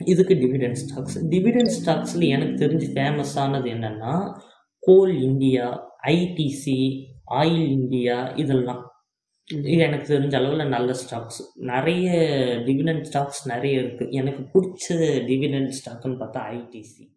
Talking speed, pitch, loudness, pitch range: 110 wpm, 135 Hz, -22 LUFS, 130-160 Hz